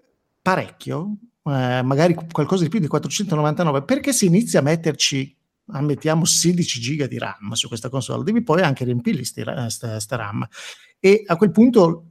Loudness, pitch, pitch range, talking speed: -20 LUFS, 155 Hz, 130-185 Hz, 155 wpm